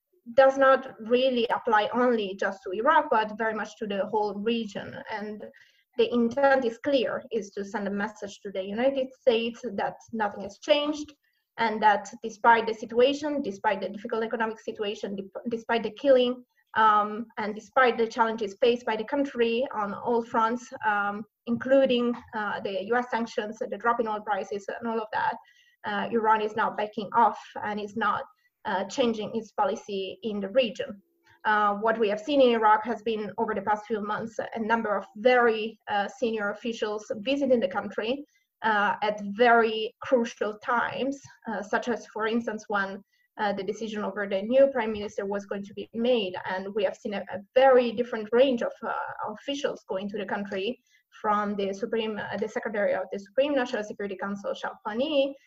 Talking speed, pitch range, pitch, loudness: 180 wpm, 210-250 Hz, 225 Hz, -27 LUFS